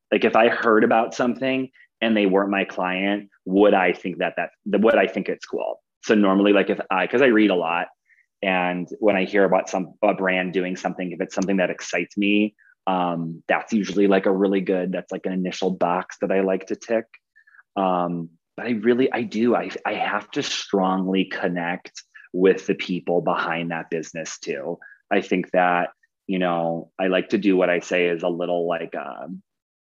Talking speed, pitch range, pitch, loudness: 200 wpm, 90-100 Hz, 95 Hz, -22 LUFS